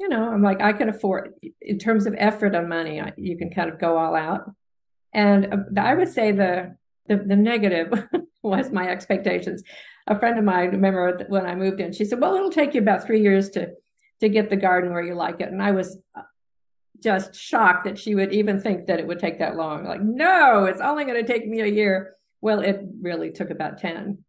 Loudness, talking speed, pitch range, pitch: -22 LUFS, 225 wpm, 185-220 Hz, 200 Hz